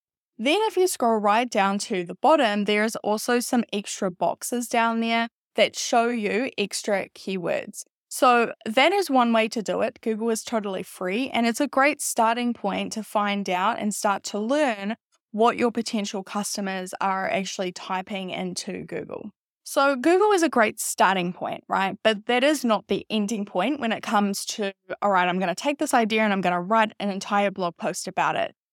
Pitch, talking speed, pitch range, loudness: 215 Hz, 195 wpm, 195-240 Hz, -24 LUFS